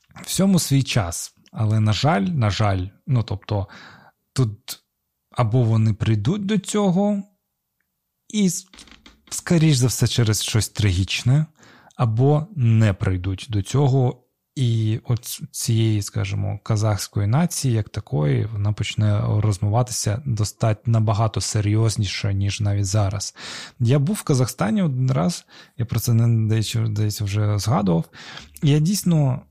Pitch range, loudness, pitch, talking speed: 105-140 Hz, -21 LUFS, 115 Hz, 120 wpm